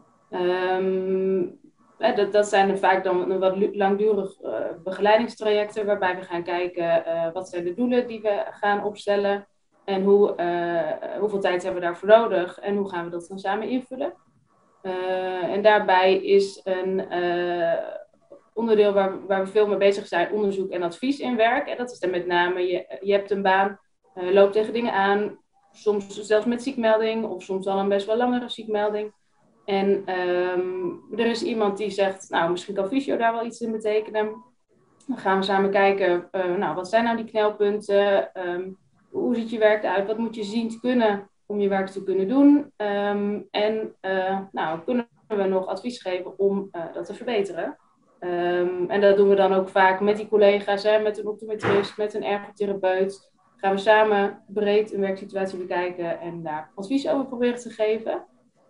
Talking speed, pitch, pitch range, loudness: 185 wpm, 200 Hz, 185-215 Hz, -23 LUFS